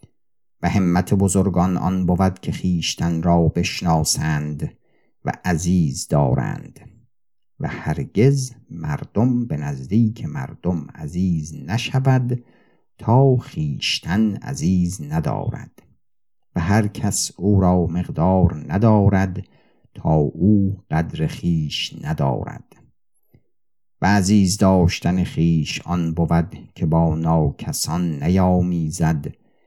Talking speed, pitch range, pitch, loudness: 95 wpm, 85-110 Hz, 95 Hz, -20 LUFS